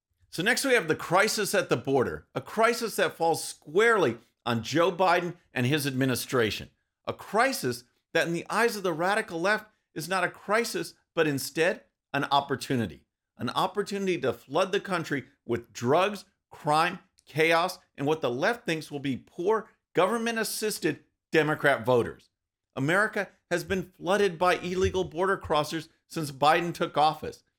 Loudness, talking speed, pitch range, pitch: -27 LUFS, 155 wpm, 145-200 Hz, 170 Hz